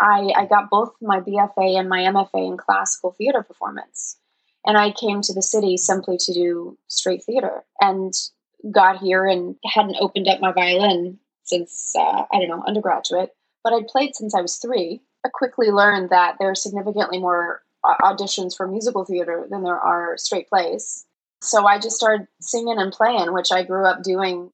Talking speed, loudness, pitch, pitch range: 185 wpm, -20 LUFS, 195 Hz, 185-215 Hz